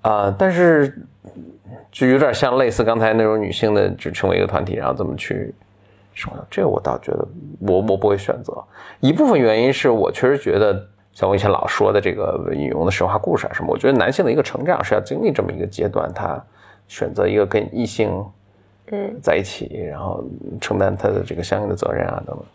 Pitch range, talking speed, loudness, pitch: 100-120 Hz, 320 characters per minute, -19 LUFS, 105 Hz